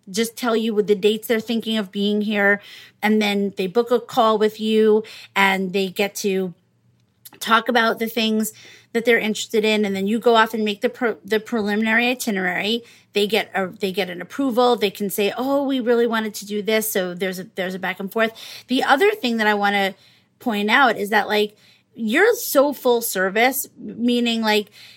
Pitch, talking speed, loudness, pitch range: 215 Hz, 205 wpm, -20 LUFS, 200-235 Hz